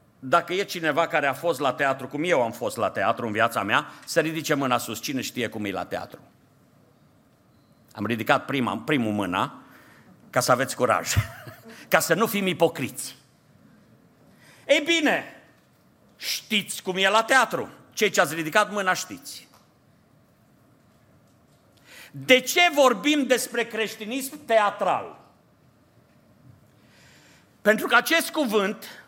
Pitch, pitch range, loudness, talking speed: 185 Hz, 140-230 Hz, -23 LUFS, 130 wpm